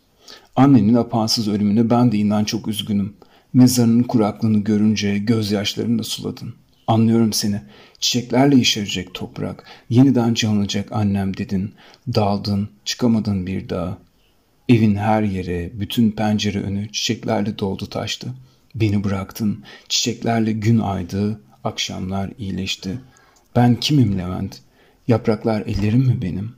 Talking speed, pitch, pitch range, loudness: 115 wpm, 105 Hz, 100-115 Hz, -19 LUFS